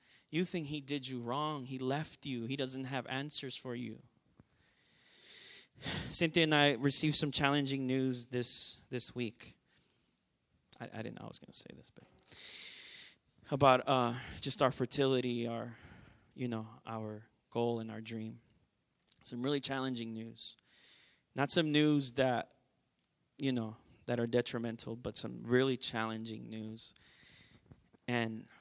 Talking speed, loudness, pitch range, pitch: 145 wpm, -35 LUFS, 115-135 Hz, 125 Hz